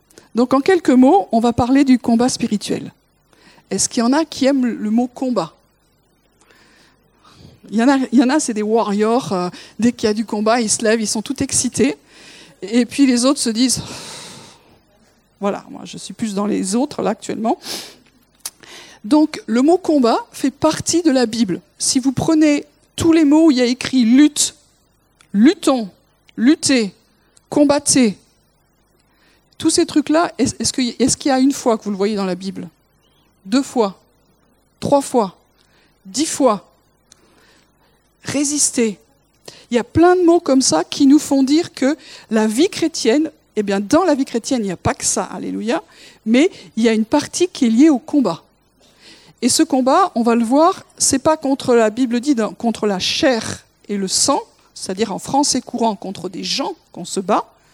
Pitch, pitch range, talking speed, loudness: 250 Hz, 220-290 Hz, 185 wpm, -16 LUFS